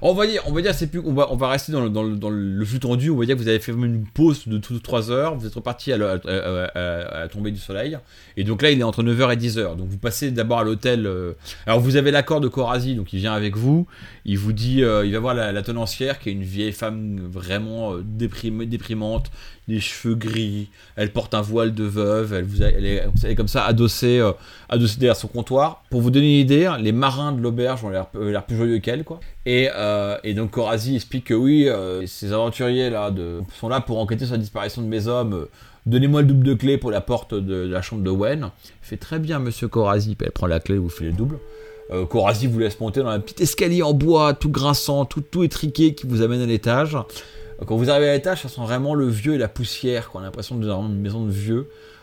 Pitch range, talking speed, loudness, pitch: 105-130 Hz, 245 wpm, -21 LUFS, 115 Hz